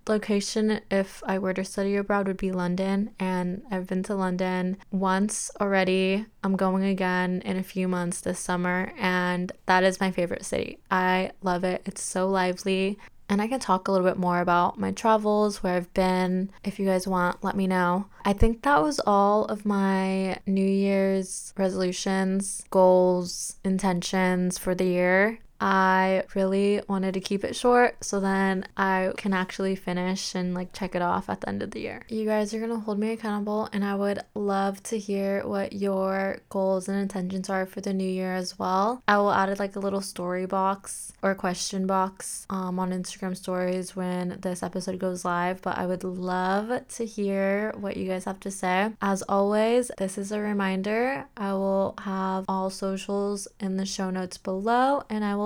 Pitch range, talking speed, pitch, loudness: 185-200 Hz, 190 wpm, 190 Hz, -26 LUFS